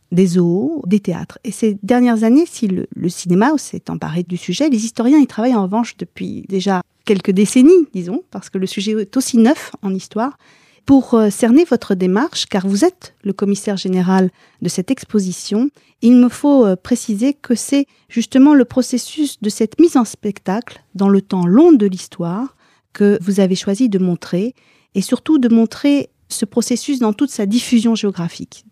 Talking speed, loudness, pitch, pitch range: 185 wpm, -15 LUFS, 220 Hz, 195-255 Hz